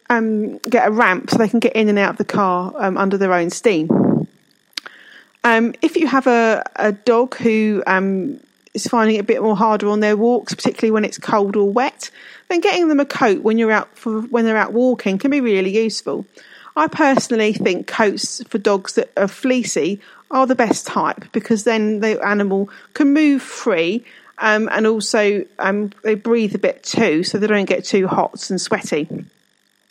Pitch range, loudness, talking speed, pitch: 205-240 Hz, -17 LUFS, 200 wpm, 220 Hz